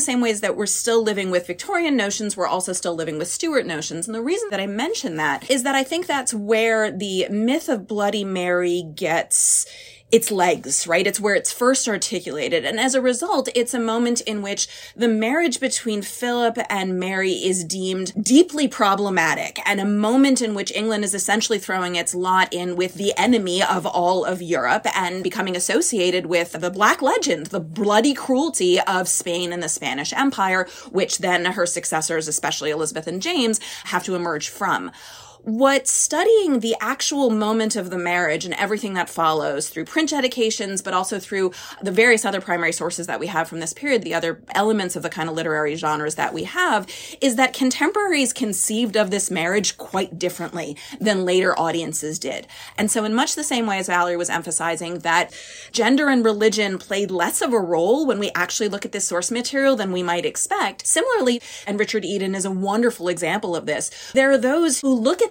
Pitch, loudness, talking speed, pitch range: 200 Hz, -20 LUFS, 195 wpm, 175-240 Hz